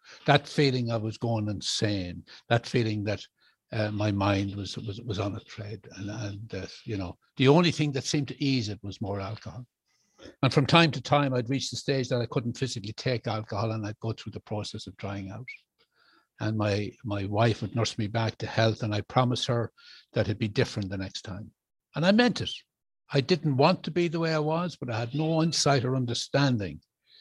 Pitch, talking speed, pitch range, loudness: 115 Hz, 220 wpm, 105-140 Hz, -28 LUFS